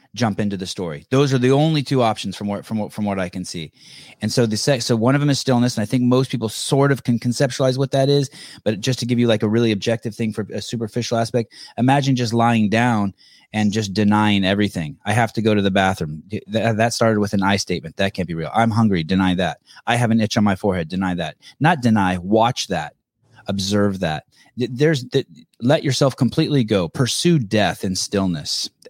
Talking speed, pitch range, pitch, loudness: 225 wpm, 100-125 Hz, 115 Hz, -19 LUFS